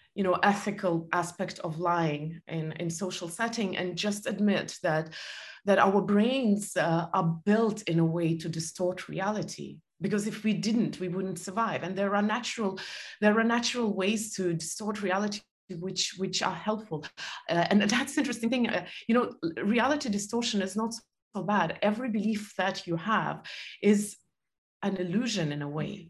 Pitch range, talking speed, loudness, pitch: 175-215 Hz, 170 wpm, -29 LUFS, 200 Hz